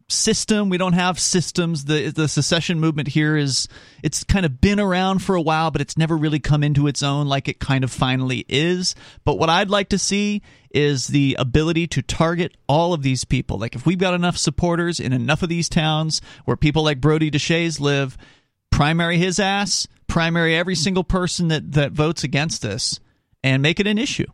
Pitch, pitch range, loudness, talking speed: 155 Hz, 140-175 Hz, -20 LUFS, 200 wpm